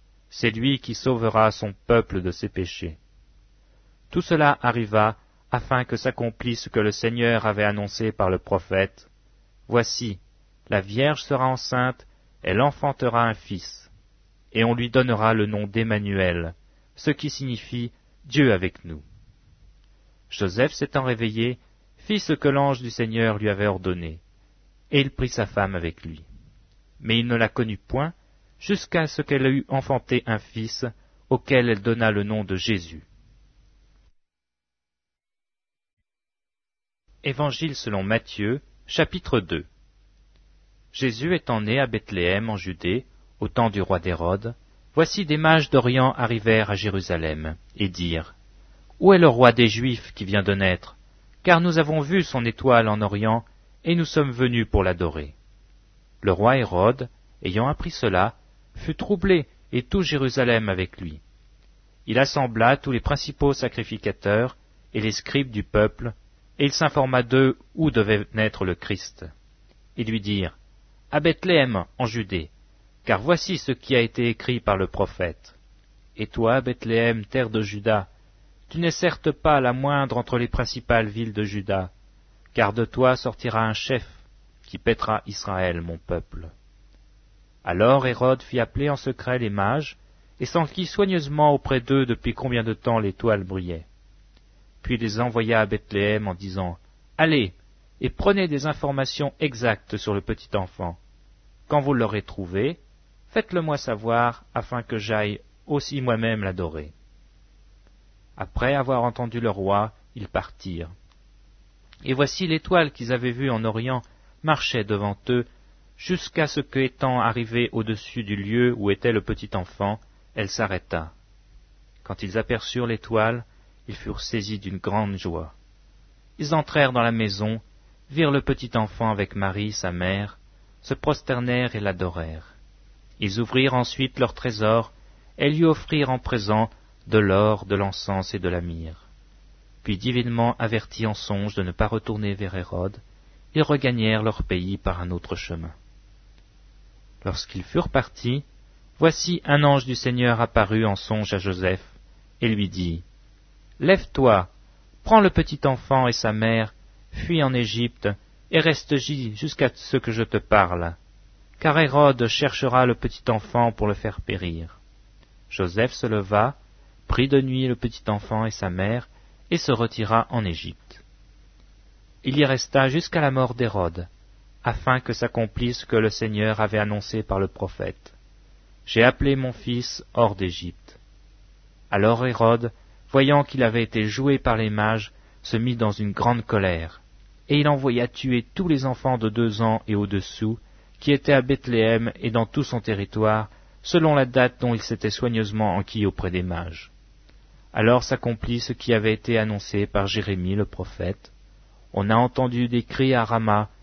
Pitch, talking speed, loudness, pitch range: 110 Hz, 150 wpm, -23 LUFS, 100-130 Hz